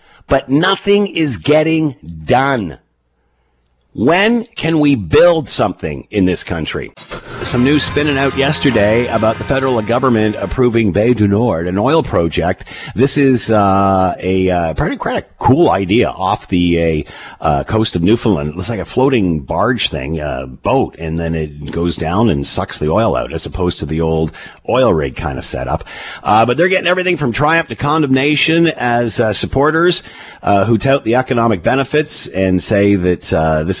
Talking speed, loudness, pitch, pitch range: 170 wpm, -14 LUFS, 110 Hz, 85-135 Hz